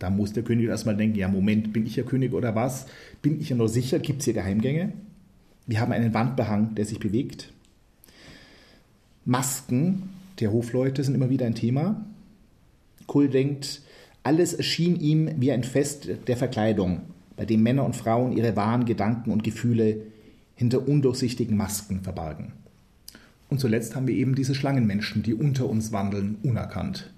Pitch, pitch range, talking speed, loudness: 120 Hz, 110-140 Hz, 165 wpm, -25 LUFS